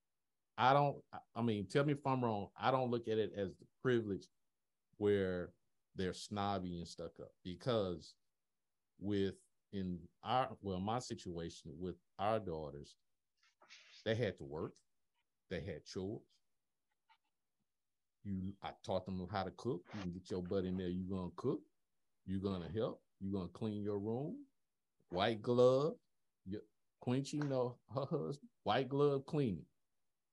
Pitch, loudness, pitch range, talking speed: 100 Hz, -40 LUFS, 95-125 Hz, 140 wpm